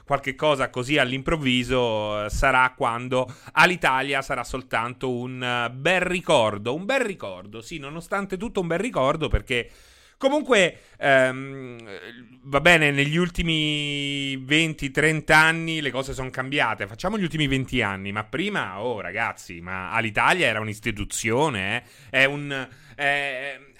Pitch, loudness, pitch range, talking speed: 135 Hz, -23 LUFS, 125-155 Hz, 130 wpm